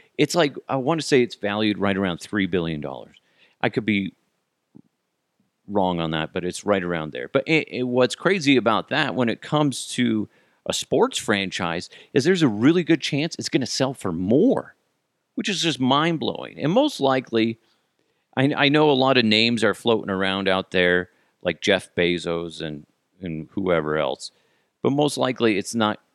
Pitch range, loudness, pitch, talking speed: 95-135 Hz, -22 LUFS, 110 Hz, 190 wpm